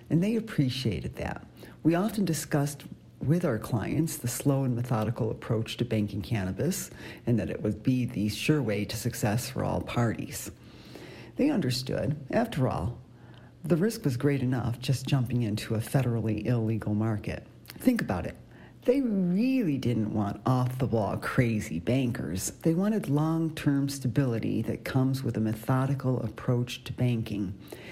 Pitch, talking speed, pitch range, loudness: 125 Hz, 155 wpm, 110-145 Hz, -29 LUFS